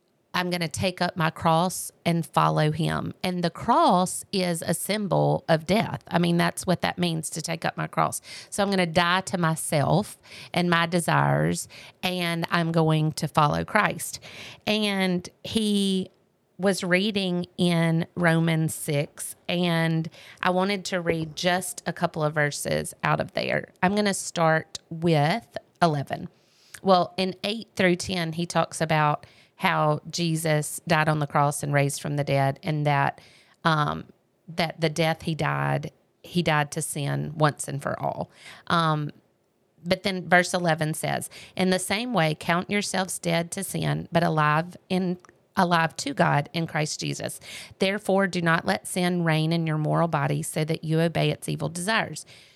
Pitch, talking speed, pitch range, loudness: 165 Hz, 170 wpm, 150-180 Hz, -25 LUFS